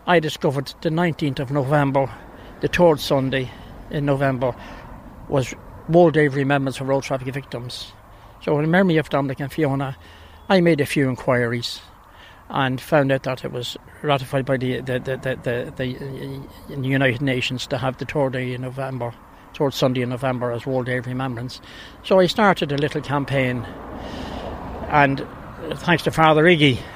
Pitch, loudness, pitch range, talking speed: 135 Hz, -21 LUFS, 125-145 Hz, 170 wpm